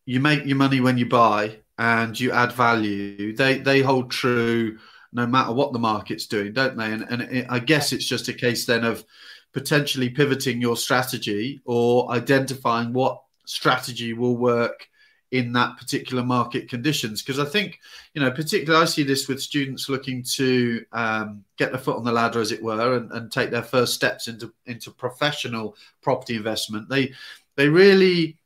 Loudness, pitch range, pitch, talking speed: -22 LUFS, 115-135 Hz, 125 Hz, 180 wpm